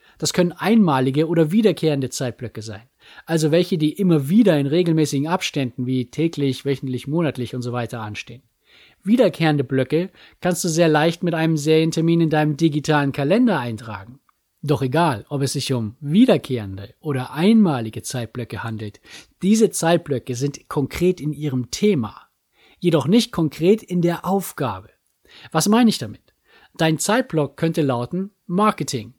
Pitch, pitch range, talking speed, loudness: 155 Hz, 130-175 Hz, 145 wpm, -20 LUFS